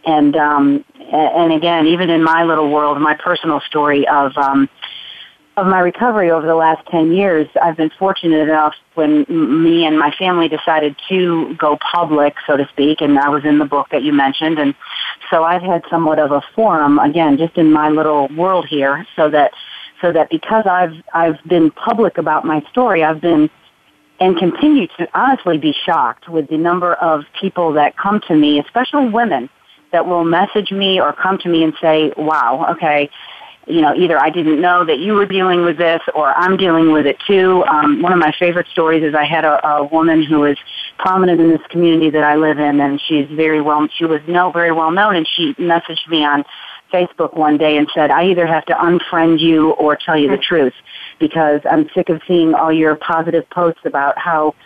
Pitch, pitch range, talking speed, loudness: 165 Hz, 150-180 Hz, 205 wpm, -14 LUFS